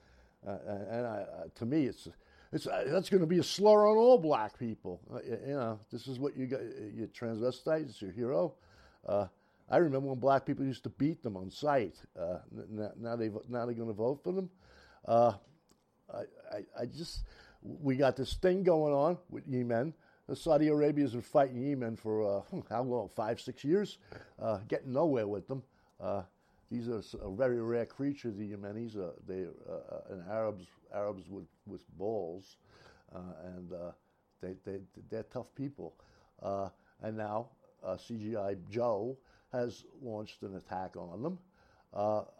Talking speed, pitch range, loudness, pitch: 180 wpm, 105-135 Hz, -34 LUFS, 115 Hz